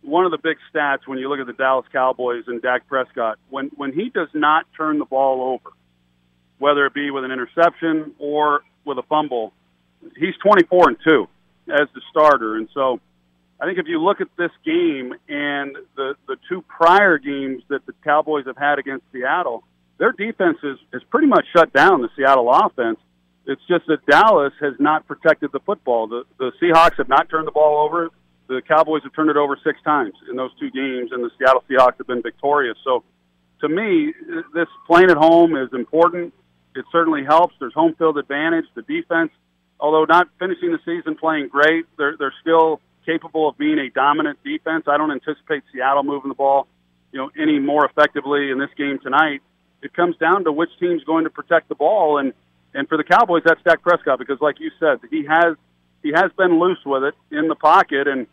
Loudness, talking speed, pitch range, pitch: -18 LUFS, 205 wpm, 130-165 Hz, 150 Hz